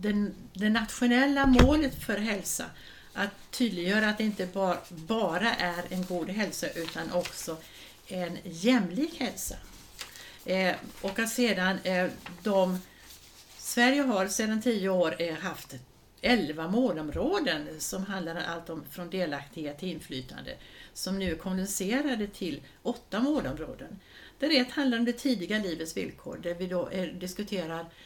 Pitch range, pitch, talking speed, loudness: 175-230 Hz, 190 Hz, 125 wpm, -30 LUFS